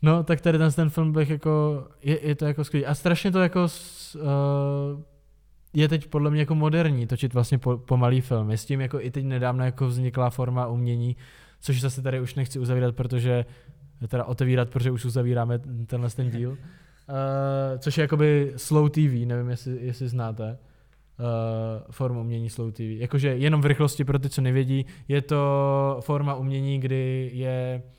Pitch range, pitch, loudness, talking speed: 125-150 Hz, 135 Hz, -25 LUFS, 185 wpm